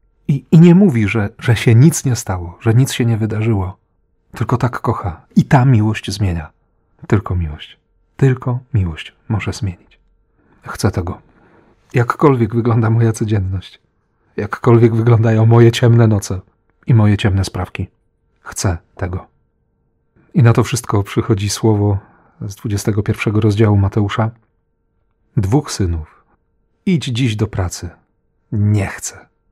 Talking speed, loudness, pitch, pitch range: 130 wpm, -15 LUFS, 110 Hz, 100-120 Hz